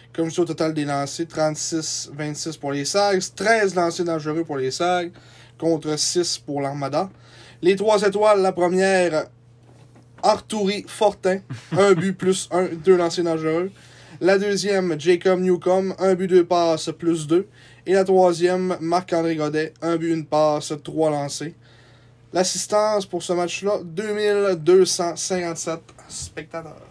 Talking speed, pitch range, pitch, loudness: 140 wpm, 150-185 Hz, 170 Hz, -21 LUFS